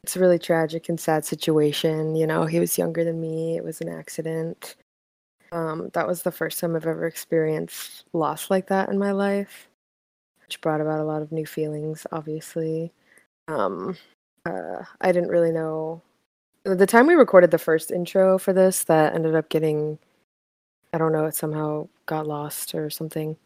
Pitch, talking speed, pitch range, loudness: 160 Hz, 180 wpm, 155-170 Hz, -23 LUFS